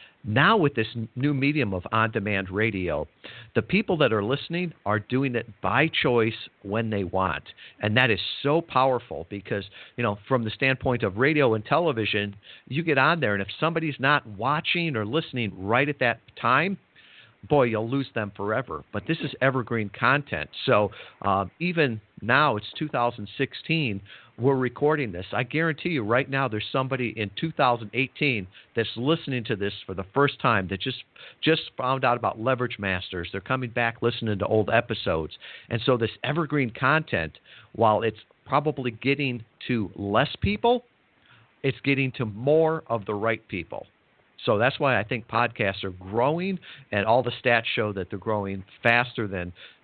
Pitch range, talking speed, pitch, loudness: 105-140 Hz, 170 wpm, 120 Hz, -25 LUFS